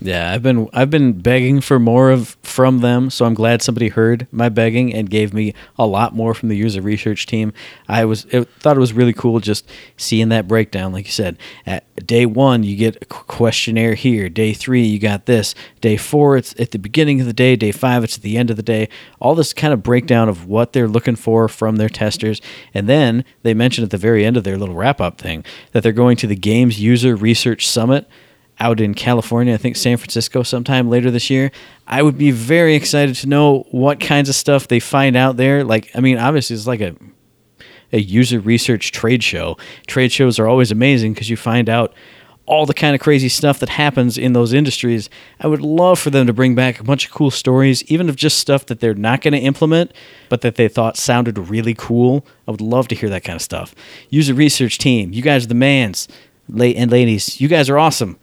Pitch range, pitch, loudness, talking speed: 110-135 Hz, 120 Hz, -15 LUFS, 230 wpm